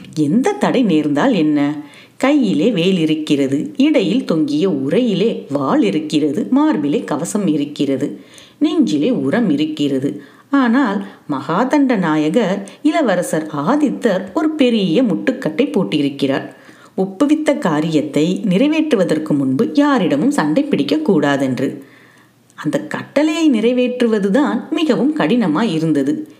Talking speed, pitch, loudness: 90 wpm, 200 Hz, -16 LUFS